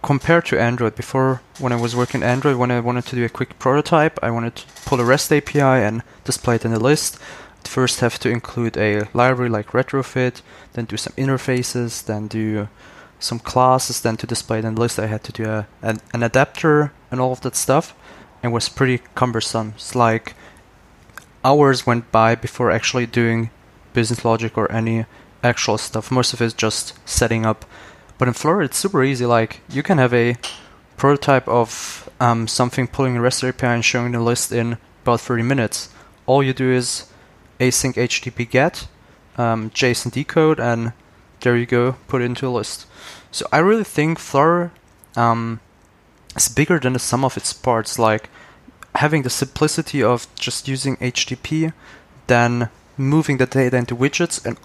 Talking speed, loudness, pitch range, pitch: 180 wpm, -19 LUFS, 115-130 Hz, 120 Hz